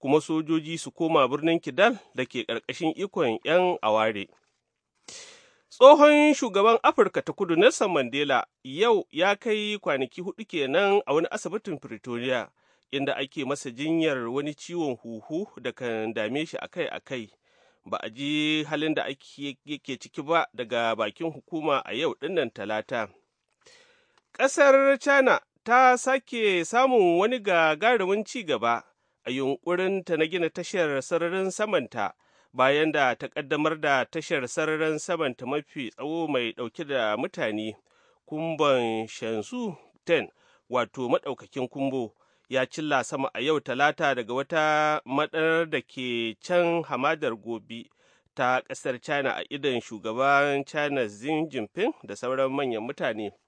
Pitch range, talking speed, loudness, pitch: 130-190 Hz, 125 wpm, -25 LUFS, 155 Hz